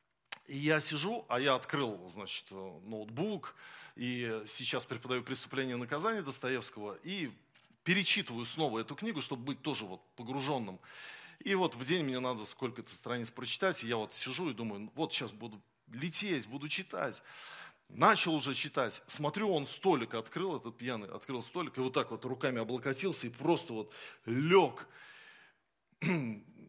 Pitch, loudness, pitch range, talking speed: 130 Hz, -35 LUFS, 115-155 Hz, 150 wpm